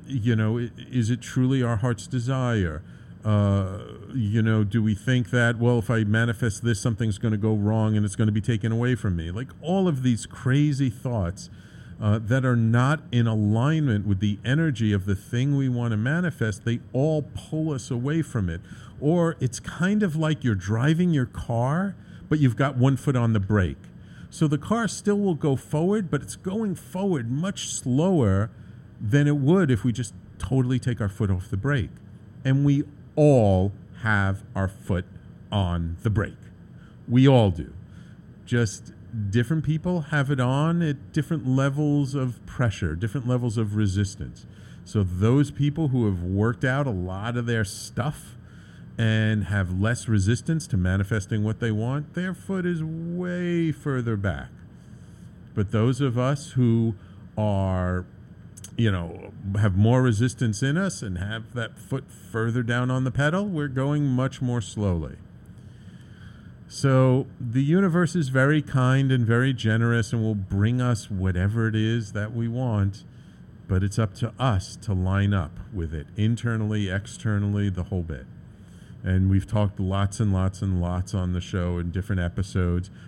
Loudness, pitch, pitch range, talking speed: -25 LUFS, 115 Hz, 100-135 Hz, 170 wpm